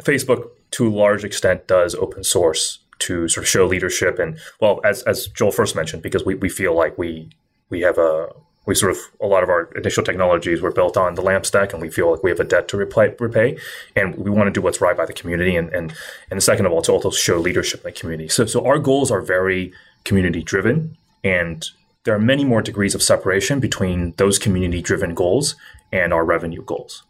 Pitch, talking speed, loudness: 110 Hz, 230 wpm, -18 LUFS